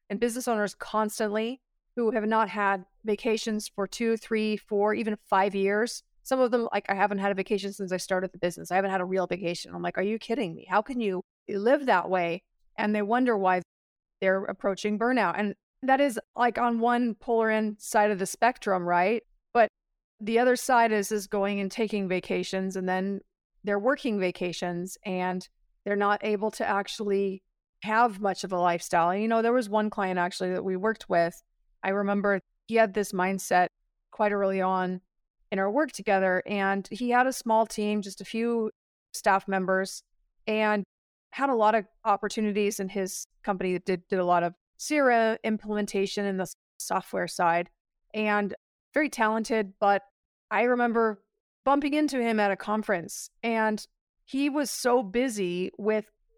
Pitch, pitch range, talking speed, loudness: 210 Hz, 190-225 Hz, 180 wpm, -27 LUFS